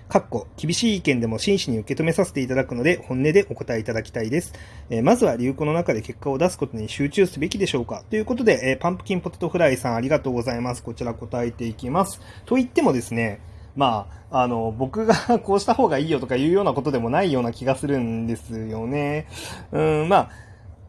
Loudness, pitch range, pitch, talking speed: -23 LUFS, 115-170 Hz, 135 Hz, 455 characters per minute